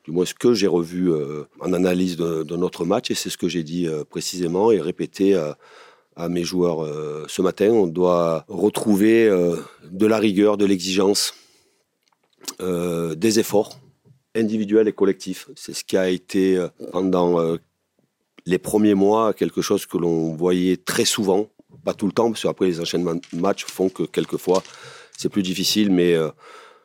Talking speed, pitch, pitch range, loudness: 180 wpm, 90 Hz, 85-100 Hz, -21 LUFS